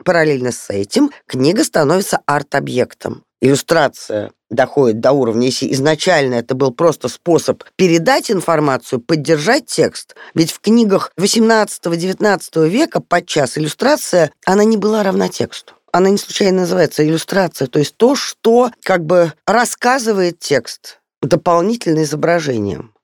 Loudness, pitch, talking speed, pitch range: -15 LUFS, 175 Hz, 125 wpm, 150-205 Hz